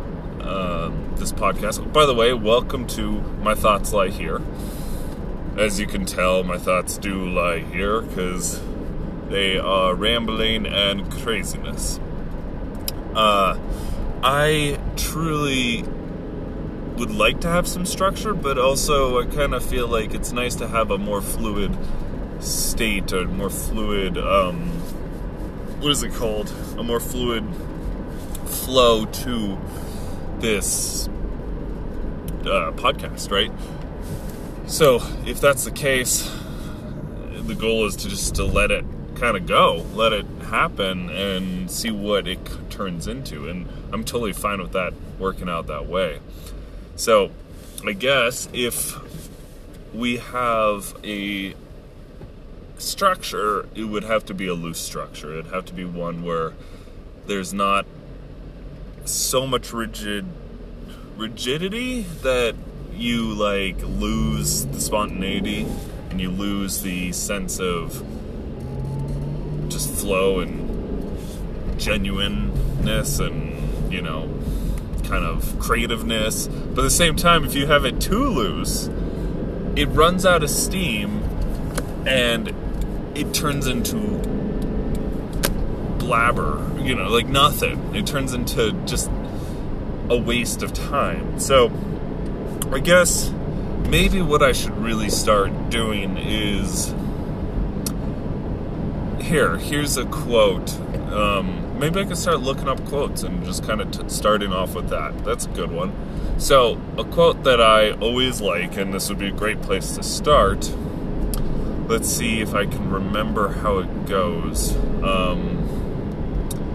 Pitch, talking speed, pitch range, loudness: 100 Hz, 125 wpm, 90-125 Hz, -22 LUFS